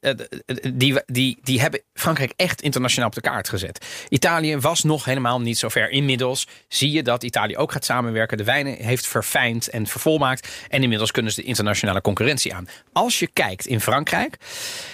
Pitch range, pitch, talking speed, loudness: 115-145 Hz, 130 Hz, 175 wpm, -21 LUFS